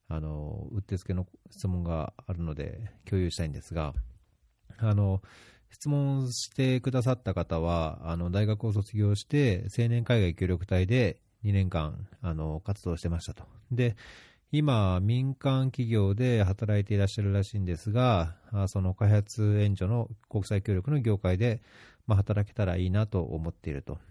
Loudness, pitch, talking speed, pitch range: -29 LUFS, 100 Hz, 295 characters per minute, 90-115 Hz